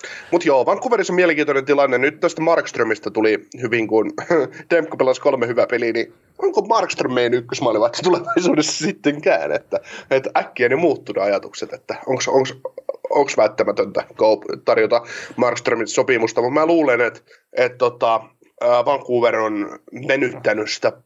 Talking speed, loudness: 135 wpm, -19 LUFS